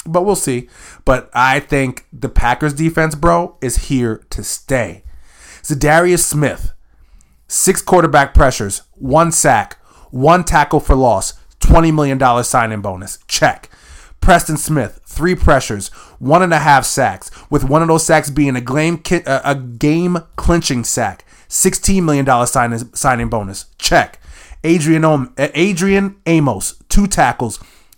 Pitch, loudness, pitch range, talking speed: 140 Hz, -14 LUFS, 115-165 Hz, 130 wpm